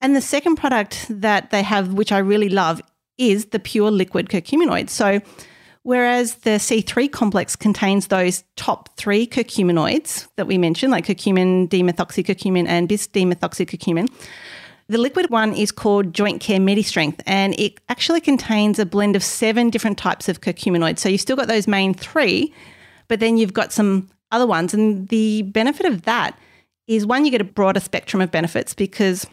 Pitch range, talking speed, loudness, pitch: 190-230 Hz, 170 wpm, -19 LUFS, 210 Hz